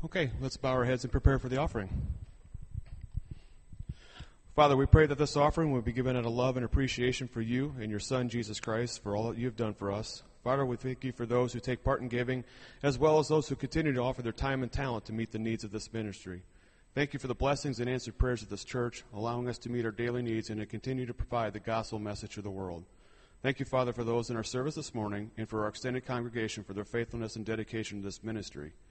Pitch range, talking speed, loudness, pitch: 110-130 Hz, 250 wpm, -33 LUFS, 120 Hz